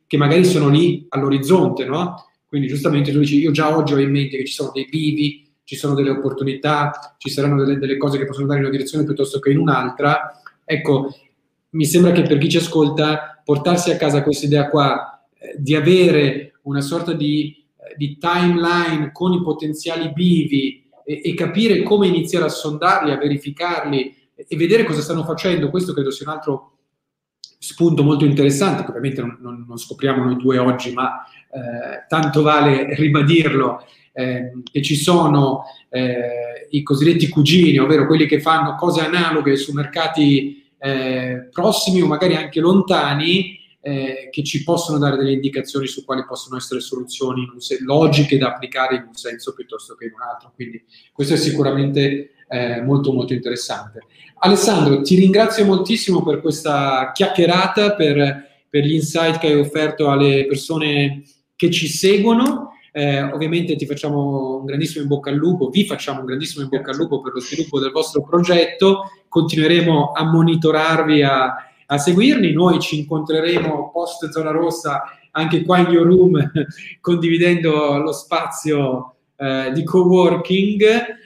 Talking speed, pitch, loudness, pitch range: 165 wpm, 150 Hz, -17 LUFS, 140-165 Hz